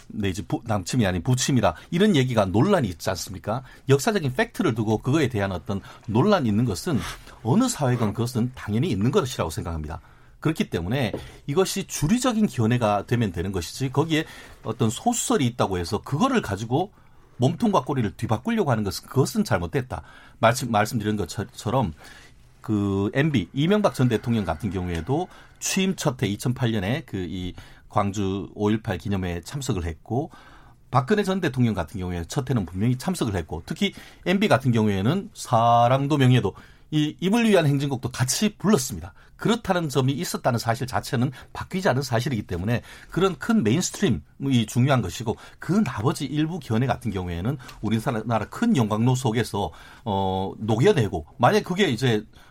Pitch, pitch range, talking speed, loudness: 120 Hz, 105-145 Hz, 355 characters per minute, -24 LUFS